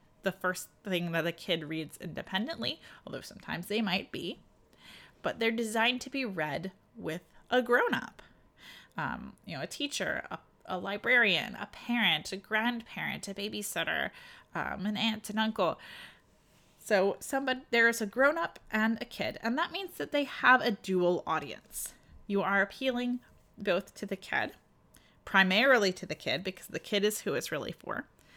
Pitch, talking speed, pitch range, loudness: 215 Hz, 165 wpm, 190-245 Hz, -31 LUFS